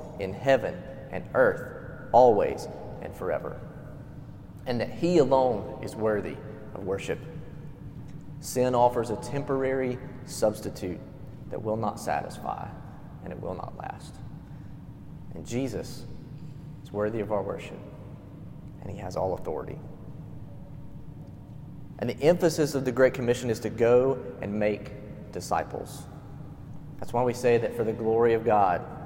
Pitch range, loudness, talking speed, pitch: 110-140 Hz, -27 LUFS, 130 wpm, 125 Hz